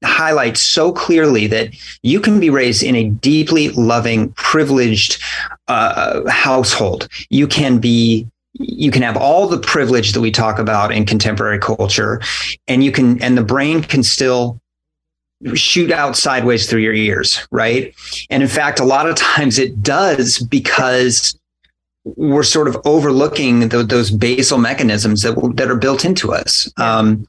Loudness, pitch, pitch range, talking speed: -13 LUFS, 125 Hz, 110-140 Hz, 155 wpm